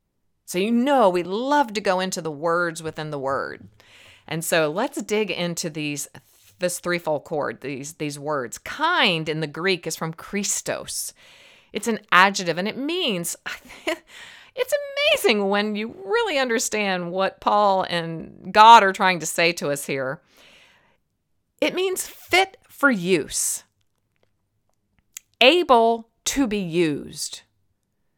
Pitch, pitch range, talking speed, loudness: 185 Hz, 160-230 Hz, 135 wpm, -21 LUFS